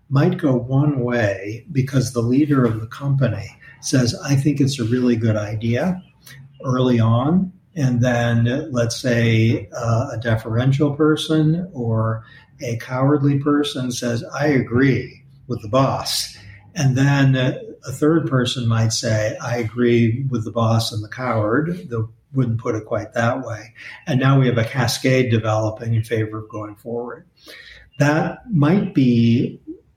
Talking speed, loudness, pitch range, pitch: 150 wpm, -19 LUFS, 115-140 Hz, 125 Hz